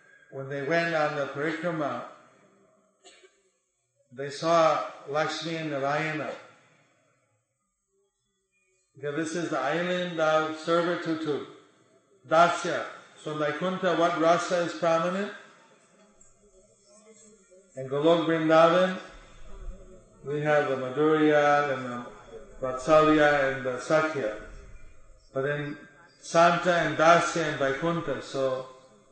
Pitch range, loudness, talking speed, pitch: 140-175 Hz, -26 LUFS, 95 wpm, 155 Hz